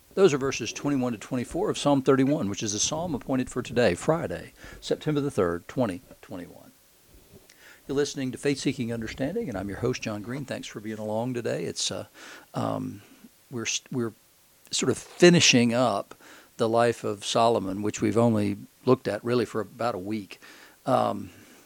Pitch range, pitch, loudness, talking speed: 110-135 Hz, 120 Hz, -26 LUFS, 170 wpm